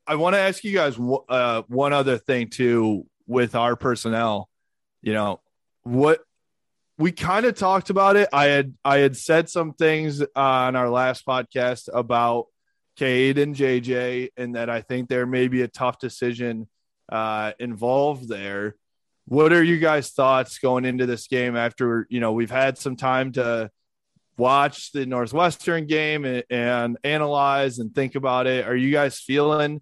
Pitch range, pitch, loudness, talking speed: 120-145 Hz, 130 Hz, -22 LUFS, 170 wpm